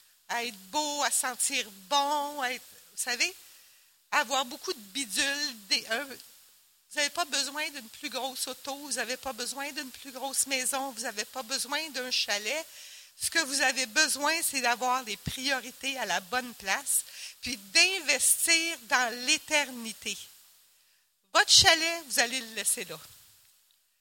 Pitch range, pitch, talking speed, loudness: 240-295 Hz, 265 Hz, 155 wpm, -28 LUFS